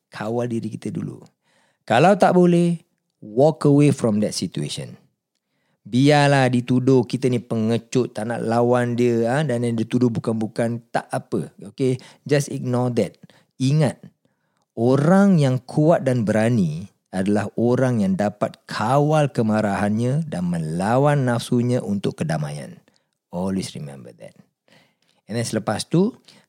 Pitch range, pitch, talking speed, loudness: 110-145 Hz, 125 Hz, 125 wpm, -20 LUFS